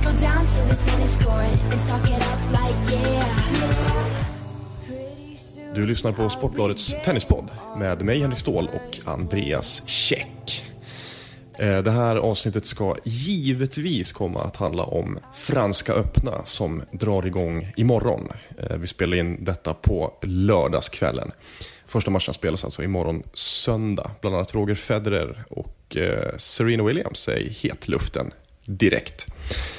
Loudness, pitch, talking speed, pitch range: -23 LUFS, 110 Hz, 105 wpm, 95-120 Hz